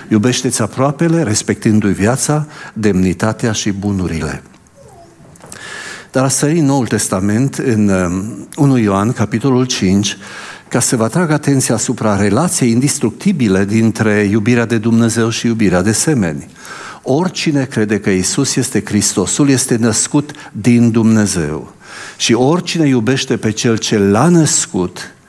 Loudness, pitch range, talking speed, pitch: -13 LUFS, 105-135 Hz, 125 wpm, 115 Hz